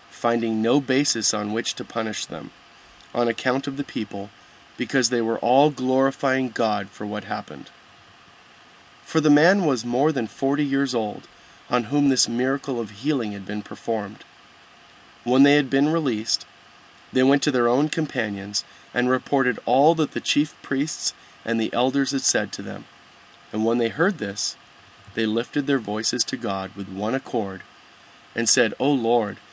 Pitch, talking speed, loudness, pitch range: 125 Hz, 170 wpm, -23 LUFS, 110-140 Hz